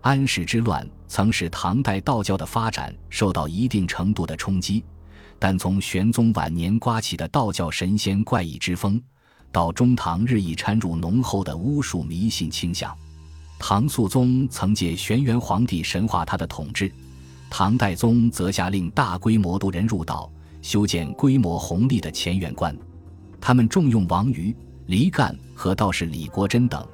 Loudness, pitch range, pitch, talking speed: -23 LUFS, 85-115 Hz, 95 Hz, 240 characters per minute